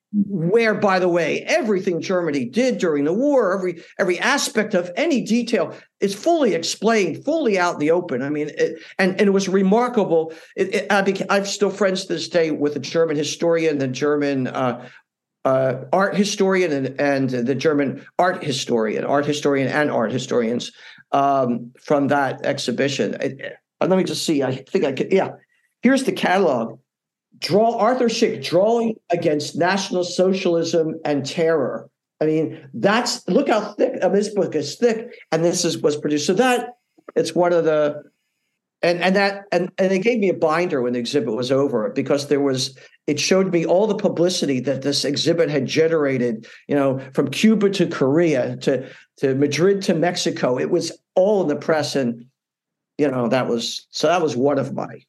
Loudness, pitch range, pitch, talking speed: -20 LUFS, 145-195 Hz, 170 Hz, 180 wpm